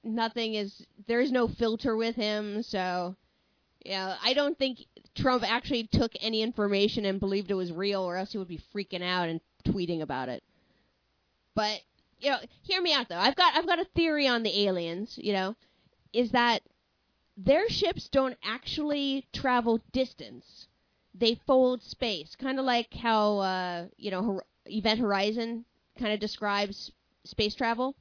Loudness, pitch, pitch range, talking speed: -29 LUFS, 220 Hz, 195-250 Hz, 165 wpm